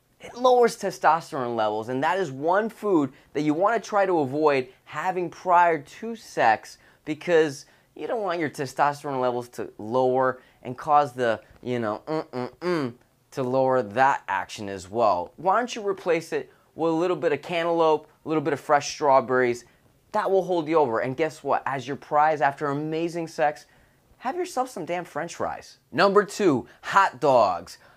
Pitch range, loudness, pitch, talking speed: 130-170 Hz, -24 LUFS, 150 Hz, 180 wpm